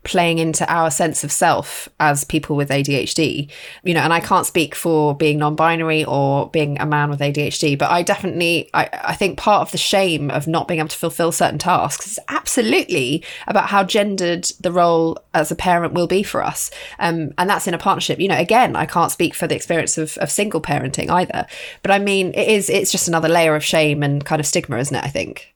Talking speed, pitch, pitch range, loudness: 225 wpm, 165 Hz, 150-180 Hz, -18 LUFS